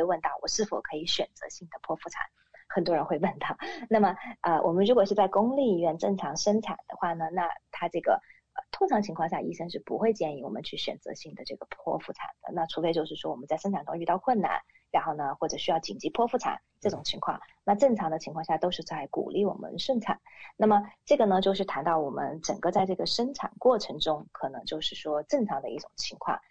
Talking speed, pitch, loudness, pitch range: 345 characters per minute, 195 Hz, -29 LUFS, 165-225 Hz